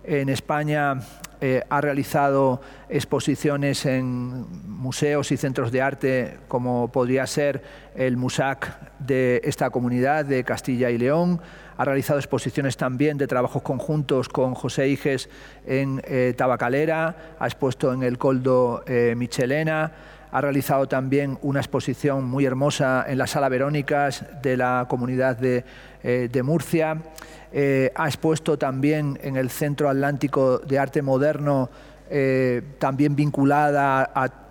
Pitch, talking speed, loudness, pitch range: 135 Hz, 135 wpm, -23 LUFS, 130-145 Hz